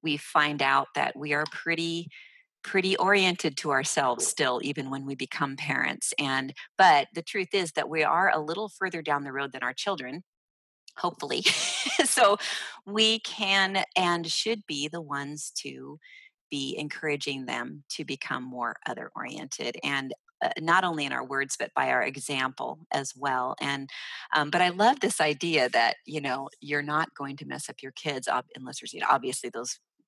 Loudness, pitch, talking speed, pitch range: -27 LUFS, 150 Hz, 180 wpm, 140-180 Hz